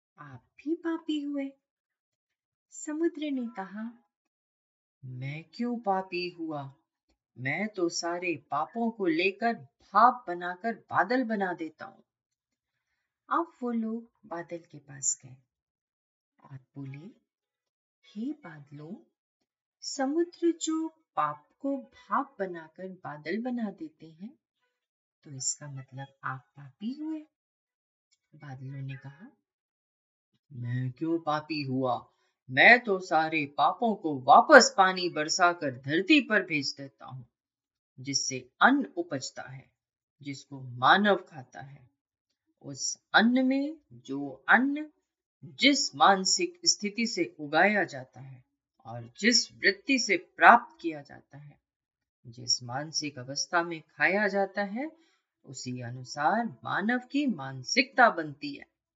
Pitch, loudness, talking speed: 170 Hz, -27 LUFS, 115 wpm